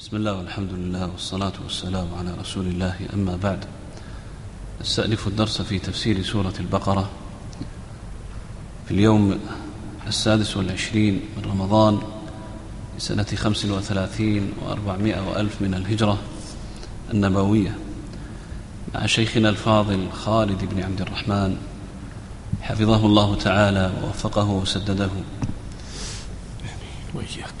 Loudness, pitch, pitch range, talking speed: -23 LUFS, 100 Hz, 95-110 Hz, 95 wpm